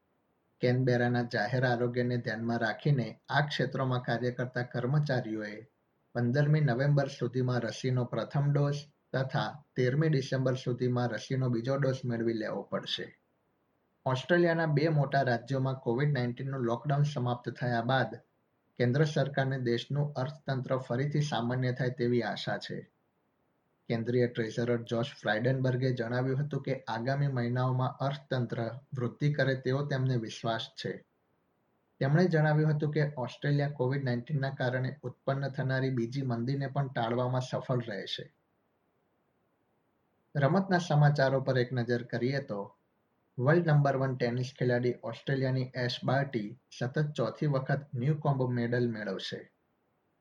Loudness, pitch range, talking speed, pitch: -31 LUFS, 120-140 Hz, 120 wpm, 130 Hz